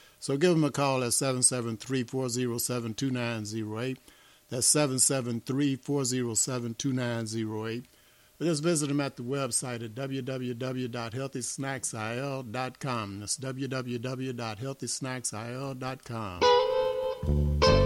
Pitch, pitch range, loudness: 130 Hz, 120-135 Hz, -29 LUFS